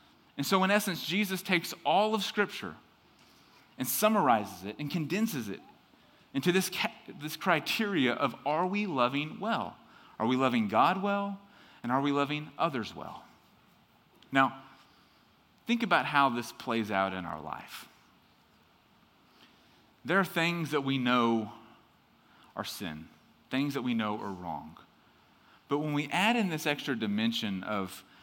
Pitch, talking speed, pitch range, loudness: 145 Hz, 145 wpm, 115-190 Hz, -30 LUFS